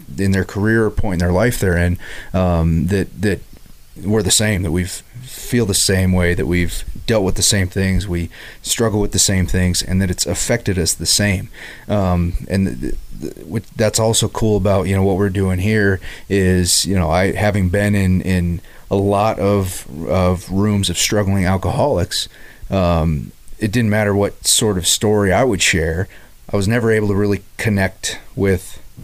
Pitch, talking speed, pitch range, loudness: 95 Hz, 190 wpm, 90-105 Hz, -17 LUFS